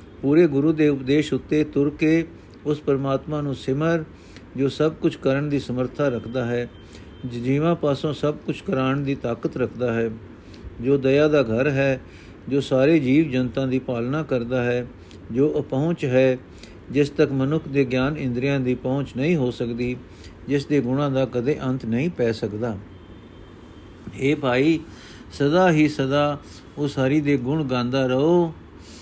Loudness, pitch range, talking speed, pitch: -22 LUFS, 120-145 Hz, 155 wpm, 135 Hz